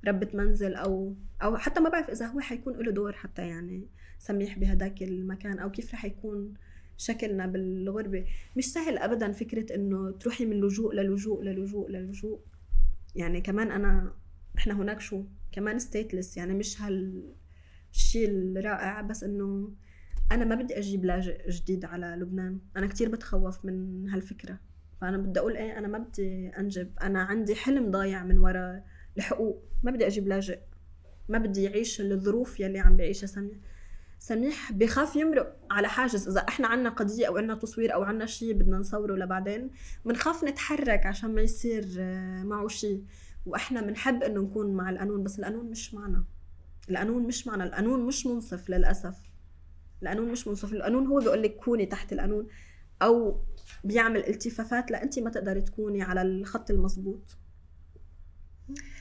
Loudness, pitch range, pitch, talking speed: -31 LUFS, 185-225 Hz, 200 Hz, 155 wpm